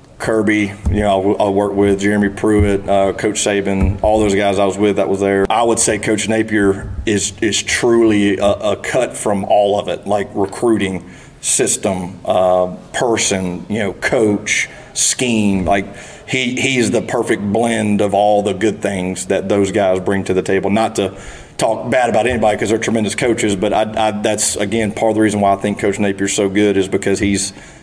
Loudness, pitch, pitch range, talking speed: -15 LUFS, 100 Hz, 100-110 Hz, 195 wpm